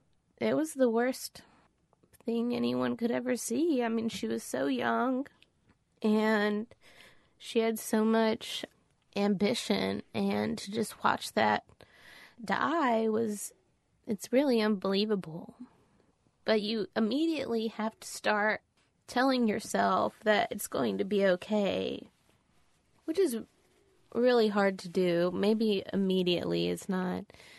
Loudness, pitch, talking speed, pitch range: -30 LUFS, 215 Hz, 120 wpm, 185-230 Hz